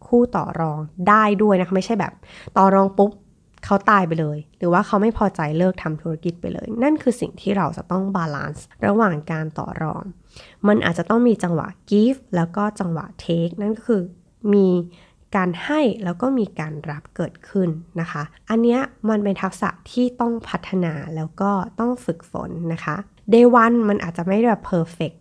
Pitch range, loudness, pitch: 170-215 Hz, -20 LUFS, 190 Hz